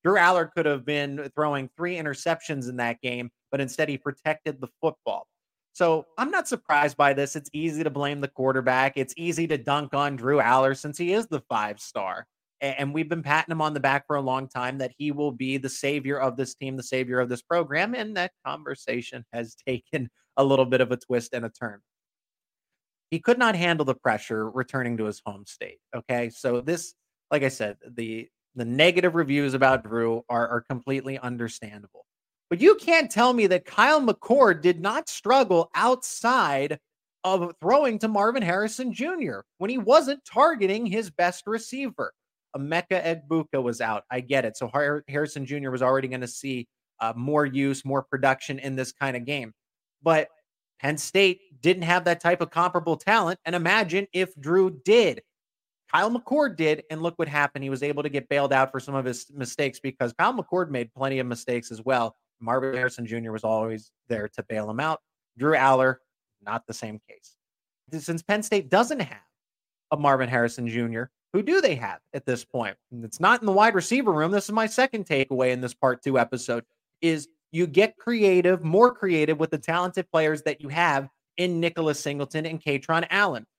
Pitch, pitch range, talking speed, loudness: 145 Hz, 130-175 Hz, 195 wpm, -25 LUFS